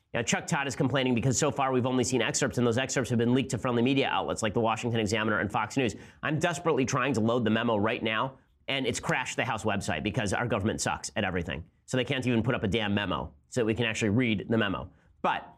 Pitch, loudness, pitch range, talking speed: 120 Hz, -28 LUFS, 110-130 Hz, 260 wpm